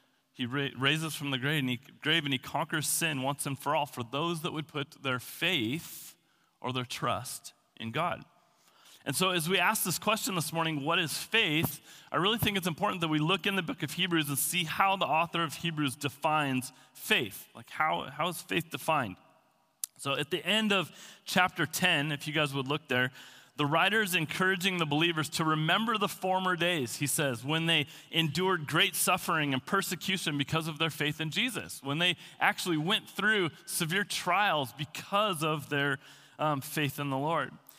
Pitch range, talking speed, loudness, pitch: 145-180 Hz, 195 wpm, -30 LUFS, 160 Hz